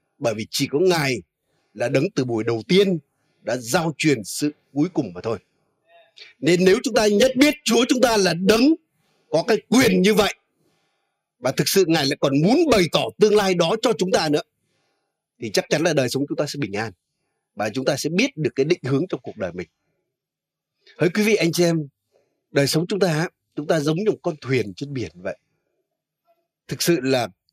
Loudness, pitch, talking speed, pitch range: -20 LUFS, 160 Hz, 215 wpm, 135-195 Hz